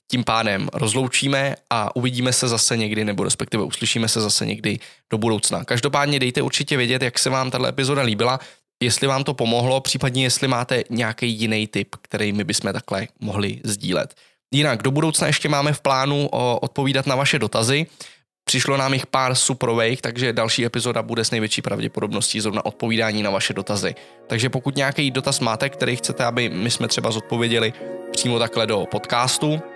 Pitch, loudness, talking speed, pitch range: 125 Hz, -20 LUFS, 175 wpm, 115-135 Hz